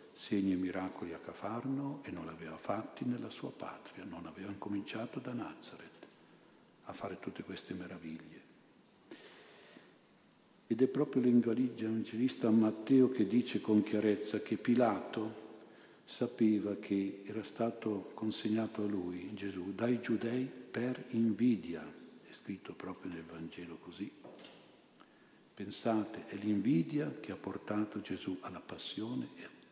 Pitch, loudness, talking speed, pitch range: 110 Hz, -37 LUFS, 130 wpm, 100-120 Hz